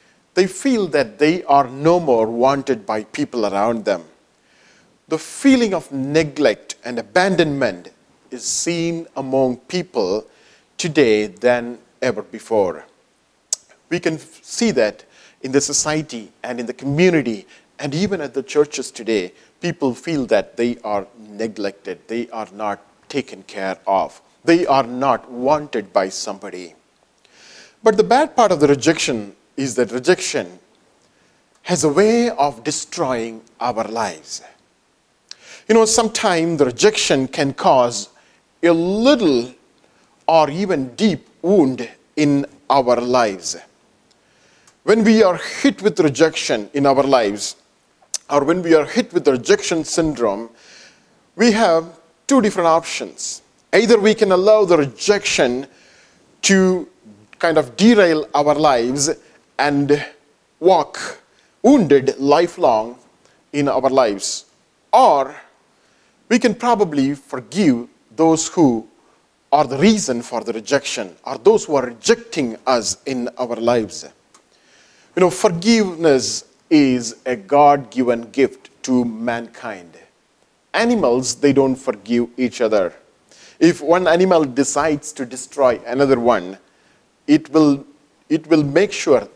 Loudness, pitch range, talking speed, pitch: -17 LUFS, 125-180 Hz, 125 wpm, 145 Hz